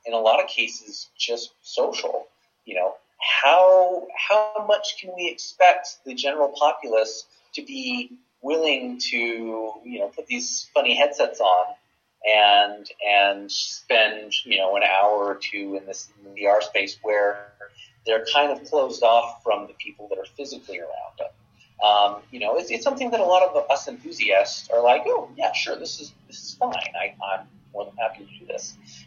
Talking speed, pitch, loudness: 180 wpm, 120 Hz, -22 LUFS